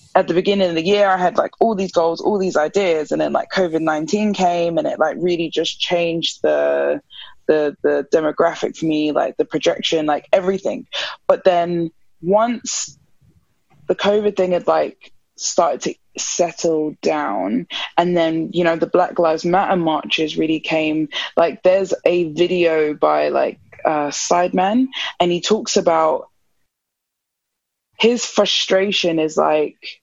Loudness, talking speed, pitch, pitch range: -18 LUFS, 150 wpm, 175 Hz, 160-190 Hz